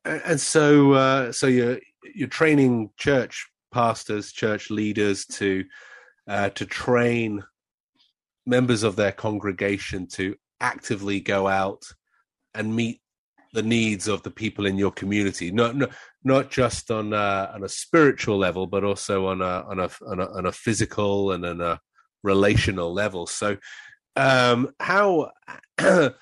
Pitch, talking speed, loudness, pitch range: 105 Hz, 140 wpm, -23 LUFS, 100-120 Hz